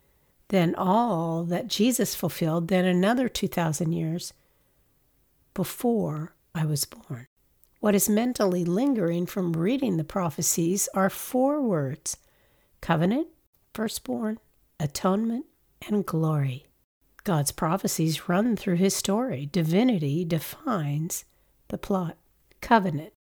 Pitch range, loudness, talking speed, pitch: 160-210 Hz, -26 LUFS, 105 wpm, 180 Hz